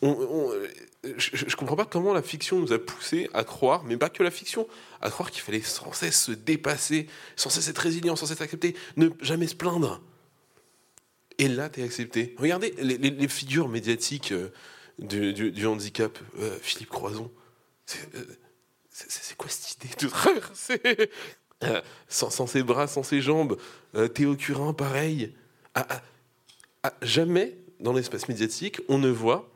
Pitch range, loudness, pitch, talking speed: 120-170 Hz, -27 LUFS, 145 Hz, 180 wpm